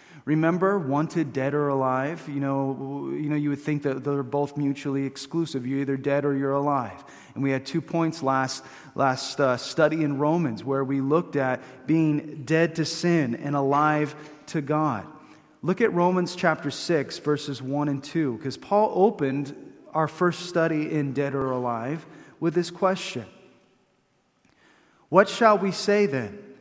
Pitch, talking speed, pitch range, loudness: 145 Hz, 160 wpm, 135-165 Hz, -25 LUFS